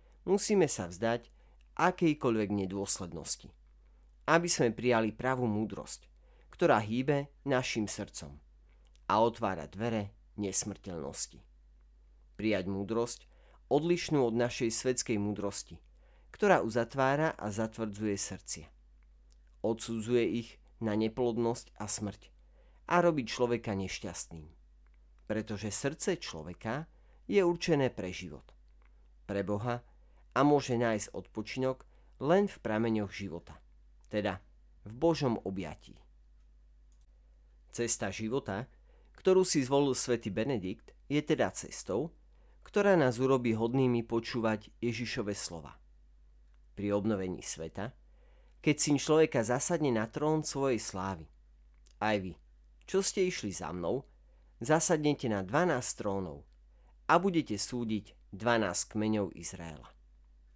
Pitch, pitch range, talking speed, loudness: 105 Hz, 80-125 Hz, 105 wpm, -32 LUFS